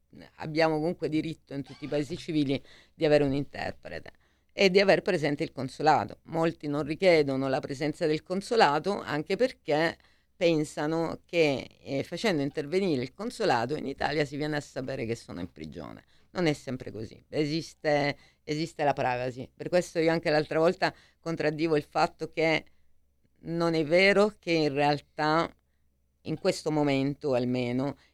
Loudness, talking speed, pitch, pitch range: -28 LUFS, 155 wpm, 150 Hz, 135-165 Hz